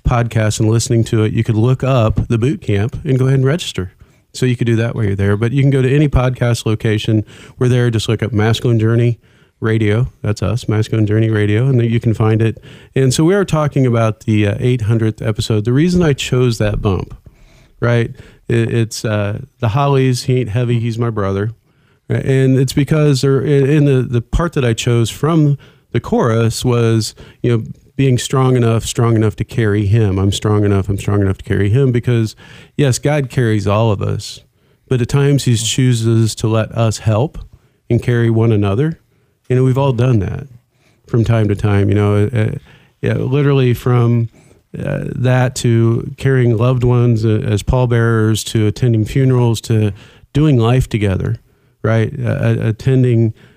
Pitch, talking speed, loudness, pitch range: 120 Hz, 185 wpm, -15 LUFS, 110-130 Hz